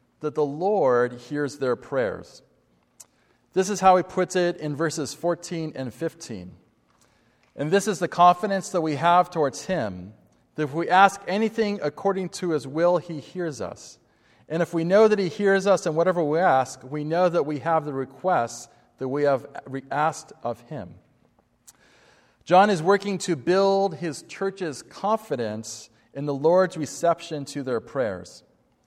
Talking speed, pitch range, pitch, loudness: 165 wpm, 140-185 Hz, 165 Hz, -24 LUFS